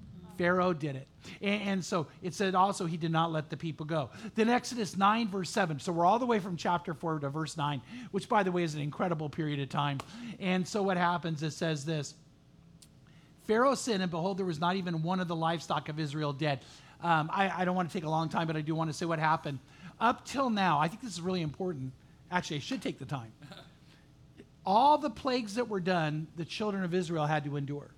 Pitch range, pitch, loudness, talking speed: 155-195 Hz, 170 Hz, -32 LUFS, 235 wpm